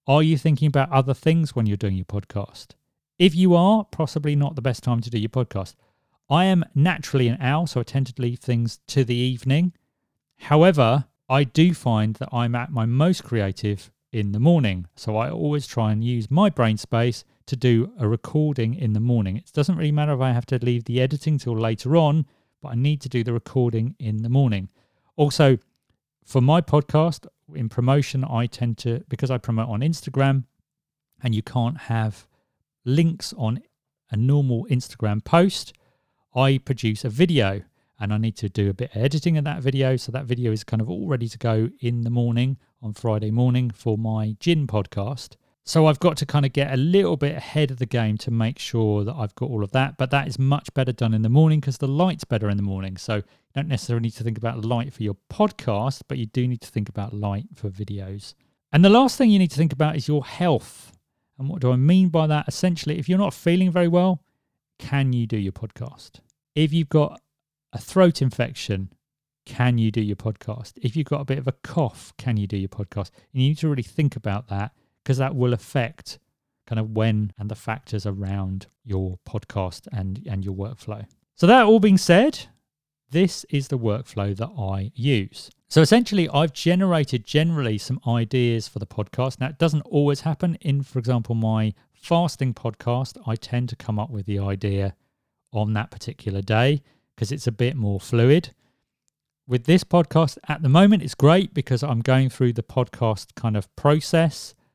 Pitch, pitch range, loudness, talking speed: 125 Hz, 110-150 Hz, -22 LUFS, 205 wpm